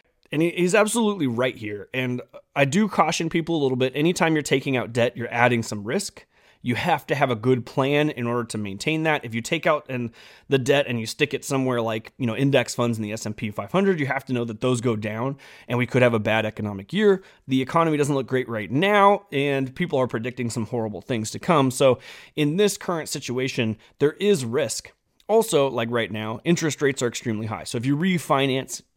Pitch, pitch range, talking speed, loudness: 130 Hz, 120-155 Hz, 225 wpm, -23 LUFS